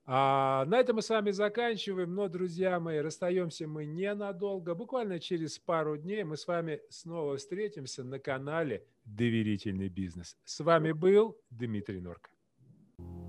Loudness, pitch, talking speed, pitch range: -33 LUFS, 165 Hz, 140 wpm, 135-195 Hz